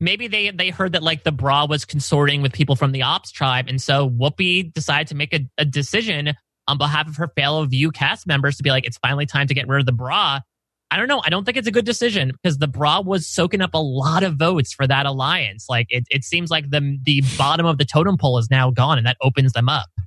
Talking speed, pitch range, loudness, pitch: 265 wpm, 135-165 Hz, -19 LUFS, 145 Hz